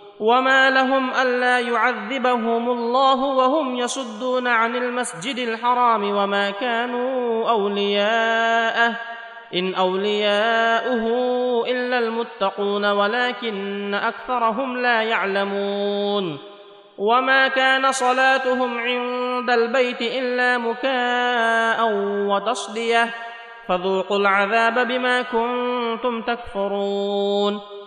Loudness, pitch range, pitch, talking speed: -20 LUFS, 205-250 Hz, 235 Hz, 75 wpm